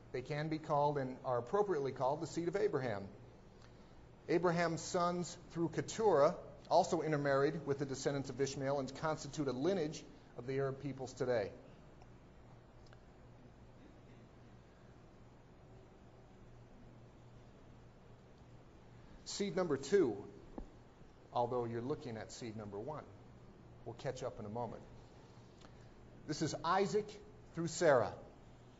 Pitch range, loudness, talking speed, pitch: 125-165 Hz, -38 LUFS, 110 wpm, 145 Hz